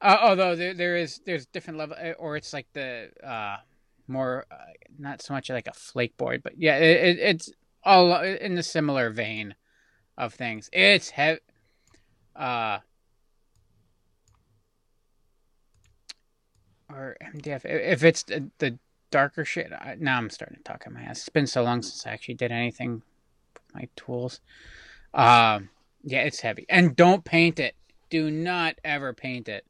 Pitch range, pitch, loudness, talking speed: 120-165 Hz, 135 Hz, -24 LUFS, 160 wpm